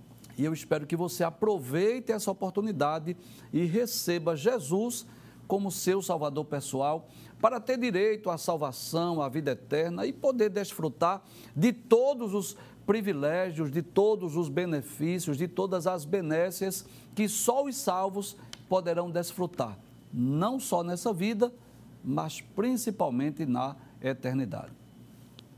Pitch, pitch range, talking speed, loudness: 180 Hz, 155-205 Hz, 120 wpm, -30 LUFS